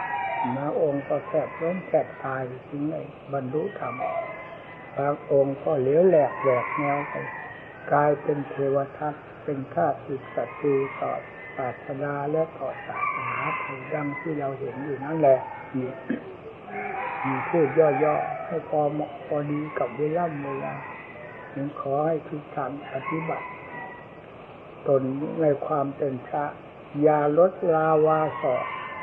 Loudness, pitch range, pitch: -26 LUFS, 140-155 Hz, 145 Hz